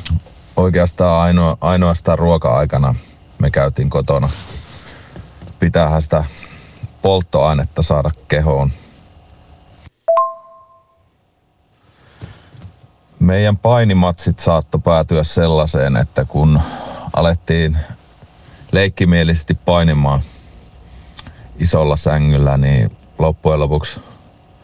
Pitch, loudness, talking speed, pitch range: 85 Hz, -15 LUFS, 65 wpm, 75-90 Hz